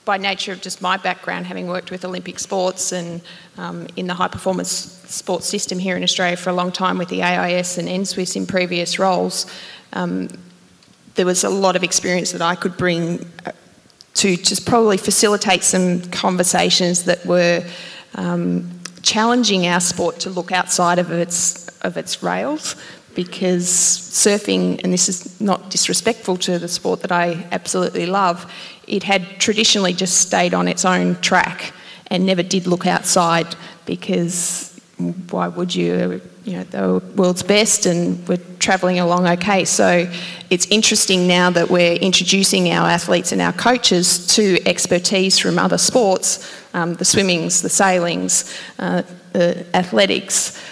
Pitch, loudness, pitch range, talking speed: 180 Hz, -17 LUFS, 175-190 Hz, 155 wpm